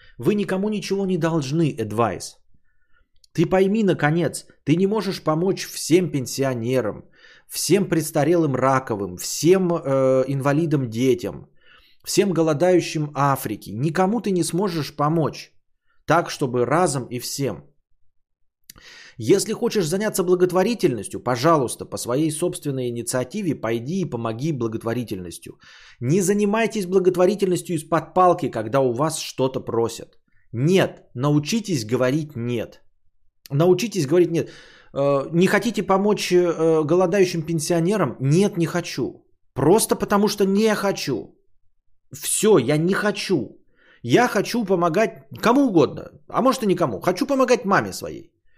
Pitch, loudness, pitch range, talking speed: 165 Hz, -21 LUFS, 130-190 Hz, 115 wpm